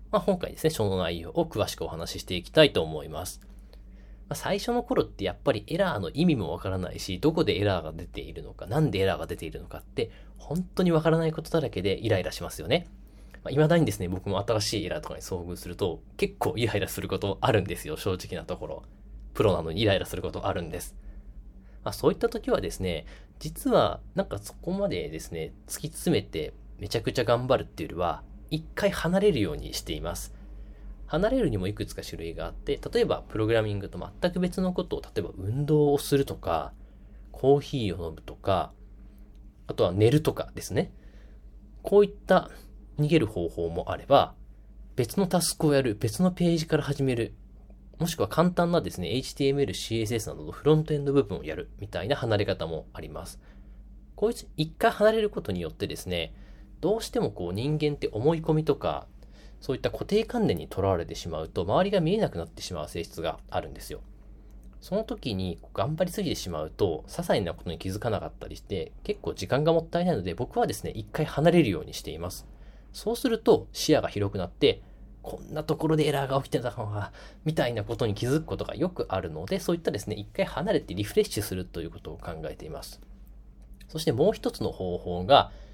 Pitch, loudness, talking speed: 110 Hz, -28 LUFS, 415 characters per minute